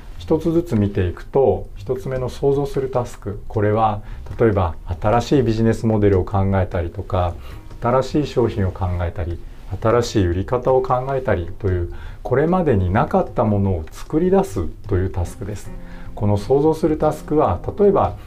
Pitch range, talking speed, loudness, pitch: 95-130 Hz, 345 characters per minute, -20 LUFS, 105 Hz